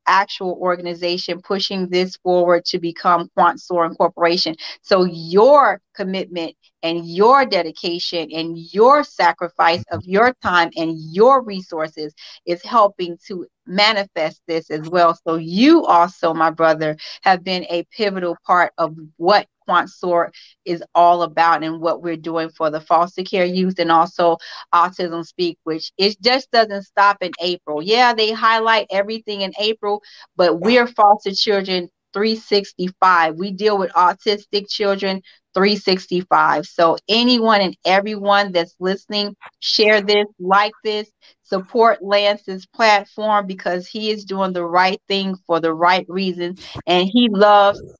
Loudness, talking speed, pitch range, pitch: -17 LUFS, 140 wpm, 170-205 Hz, 185 Hz